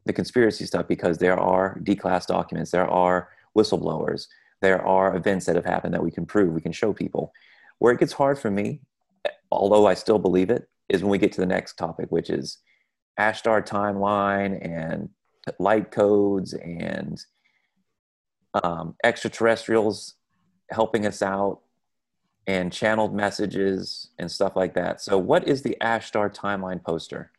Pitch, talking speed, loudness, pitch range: 100 Hz, 160 wpm, -24 LUFS, 90-110 Hz